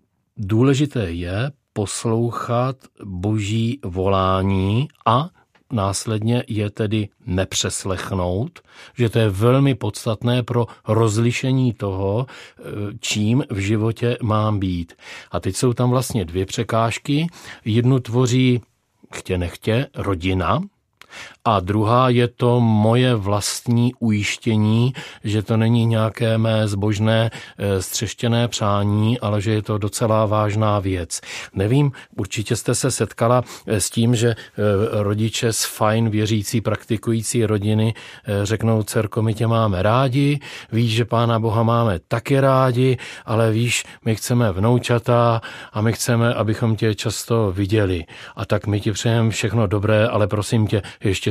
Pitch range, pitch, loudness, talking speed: 105-120 Hz, 115 Hz, -20 LUFS, 125 wpm